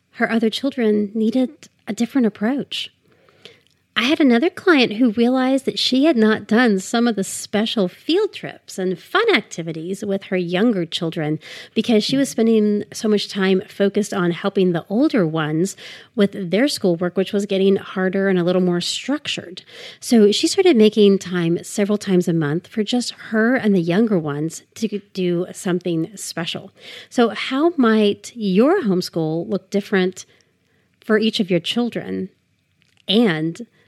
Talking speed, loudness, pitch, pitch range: 160 wpm, -19 LUFS, 205 Hz, 180-235 Hz